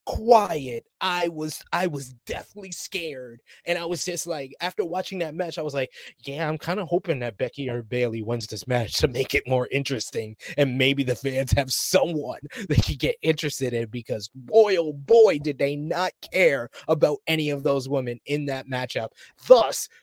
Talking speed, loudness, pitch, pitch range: 190 wpm, -24 LUFS, 145 Hz, 130-175 Hz